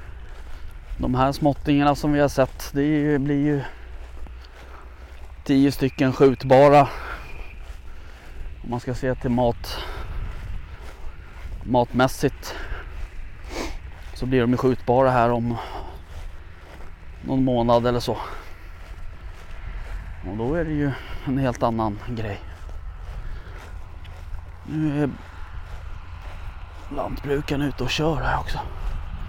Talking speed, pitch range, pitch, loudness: 95 wpm, 80-130 Hz, 90 Hz, -22 LUFS